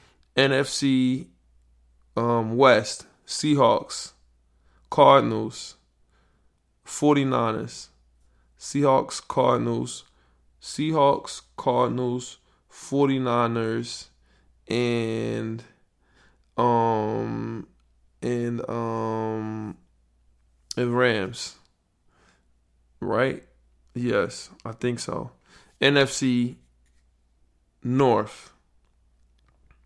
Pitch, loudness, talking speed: 105 Hz, -24 LUFS, 50 wpm